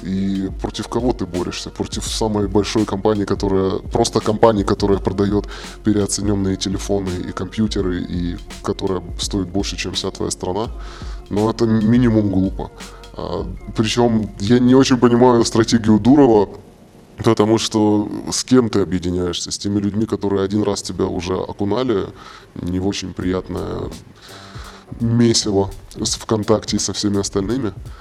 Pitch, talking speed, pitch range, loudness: 100 Hz, 135 wpm, 95-110 Hz, -18 LUFS